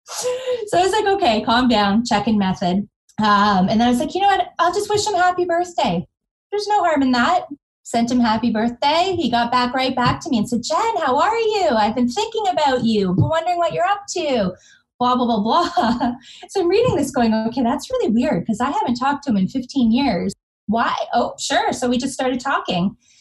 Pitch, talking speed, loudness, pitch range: 255 Hz, 230 wpm, -19 LUFS, 225-350 Hz